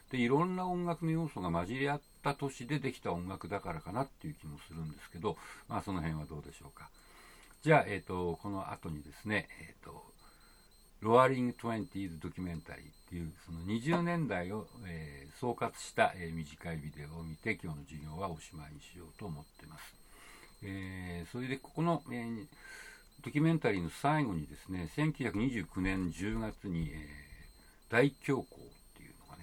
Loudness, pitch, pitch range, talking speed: -36 LUFS, 95 Hz, 80-125 Hz, 295 characters per minute